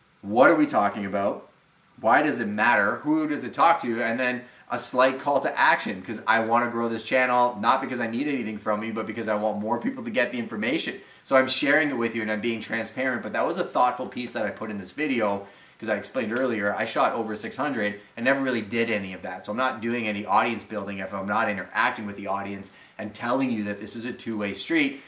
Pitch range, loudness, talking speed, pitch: 105-125 Hz, -25 LUFS, 255 wpm, 115 Hz